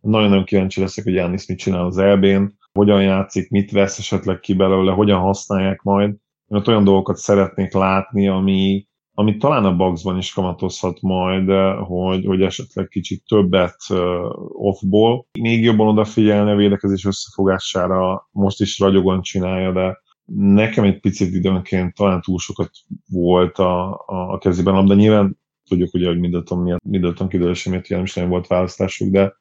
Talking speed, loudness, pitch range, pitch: 155 wpm, -17 LUFS, 95-100 Hz, 95 Hz